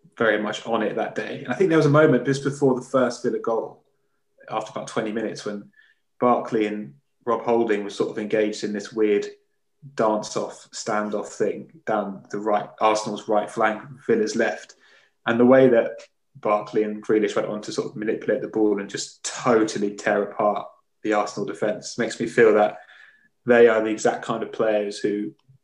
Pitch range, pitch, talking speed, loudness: 105-130 Hz, 110 Hz, 190 wpm, -23 LUFS